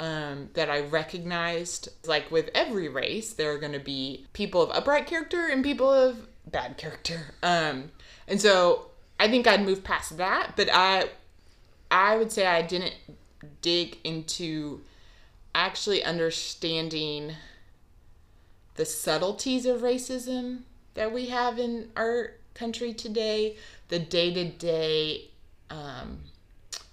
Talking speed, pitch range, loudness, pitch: 125 wpm, 160-240 Hz, -27 LUFS, 180 Hz